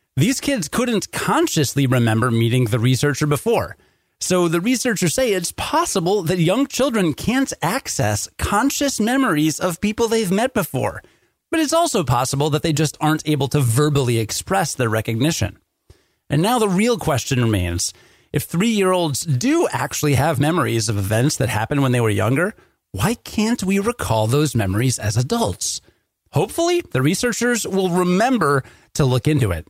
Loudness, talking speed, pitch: -19 LUFS, 160 wpm, 155 Hz